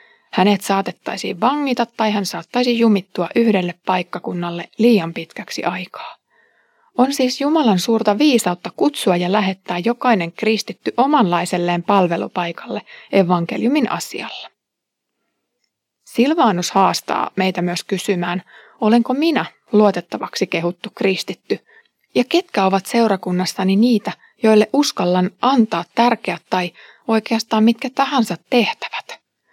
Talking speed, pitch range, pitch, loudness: 100 wpm, 180-240 Hz, 210 Hz, -18 LUFS